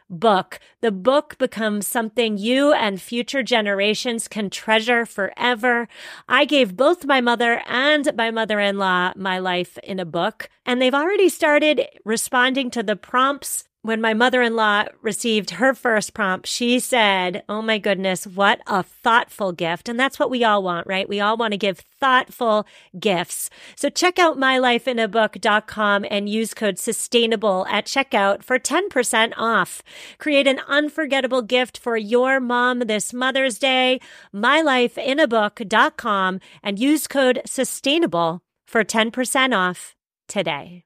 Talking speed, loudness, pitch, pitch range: 140 wpm, -20 LUFS, 230 Hz, 205-260 Hz